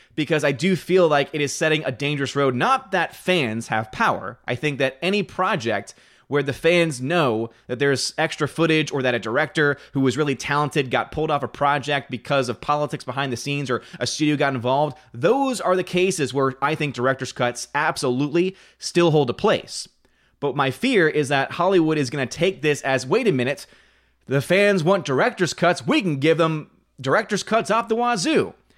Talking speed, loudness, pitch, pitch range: 200 wpm, -21 LUFS, 145 Hz, 135-170 Hz